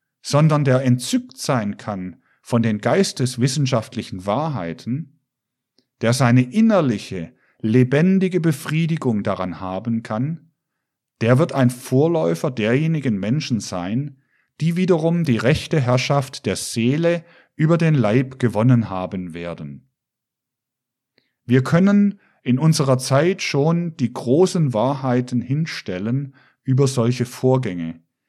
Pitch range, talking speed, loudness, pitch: 115-155 Hz, 105 wpm, -20 LUFS, 130 Hz